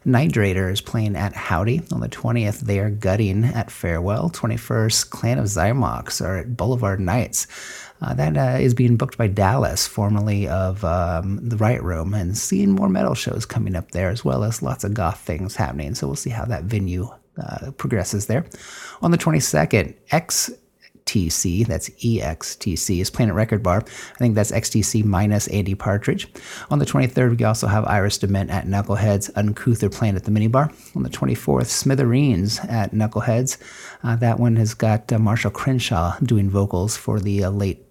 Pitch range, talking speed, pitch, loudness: 100-120 Hz, 180 wpm, 110 Hz, -21 LUFS